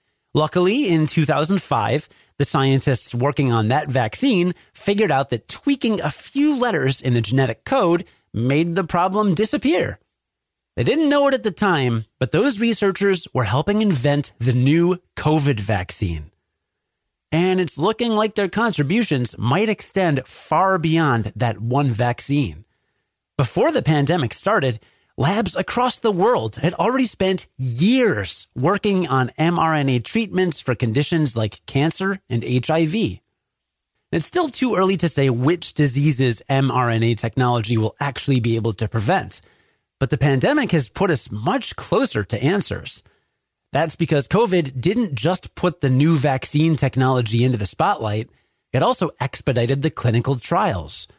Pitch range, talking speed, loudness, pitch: 125-185 Hz, 140 wpm, -20 LUFS, 145 Hz